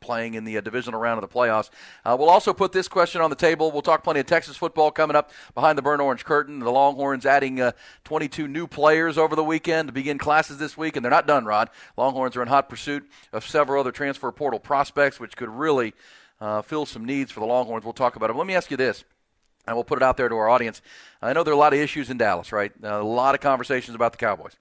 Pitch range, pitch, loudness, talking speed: 120-155 Hz, 140 Hz, -22 LUFS, 265 wpm